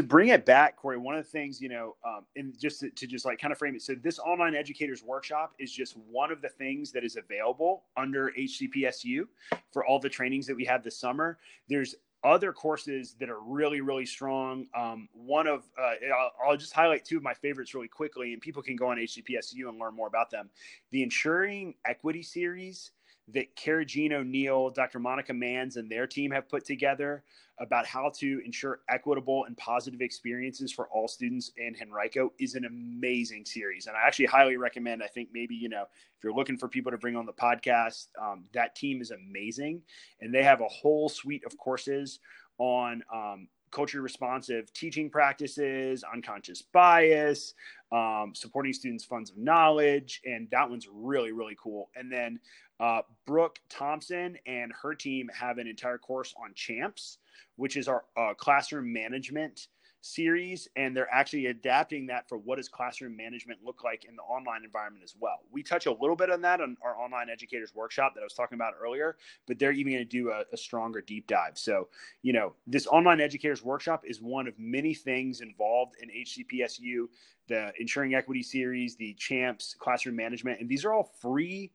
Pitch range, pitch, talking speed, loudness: 120-145 Hz, 130 Hz, 190 wpm, -30 LUFS